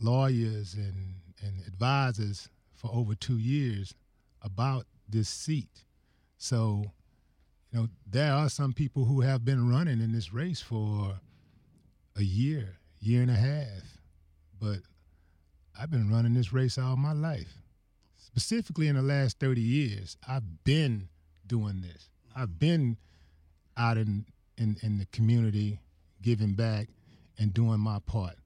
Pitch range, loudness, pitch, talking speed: 95-130 Hz, -30 LUFS, 110 Hz, 135 wpm